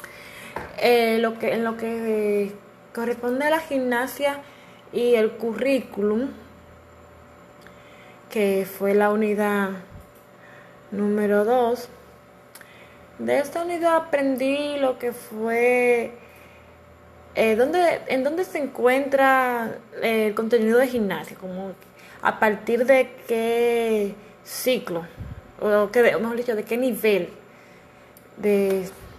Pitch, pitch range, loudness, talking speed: 225 Hz, 200-250 Hz, -22 LUFS, 105 wpm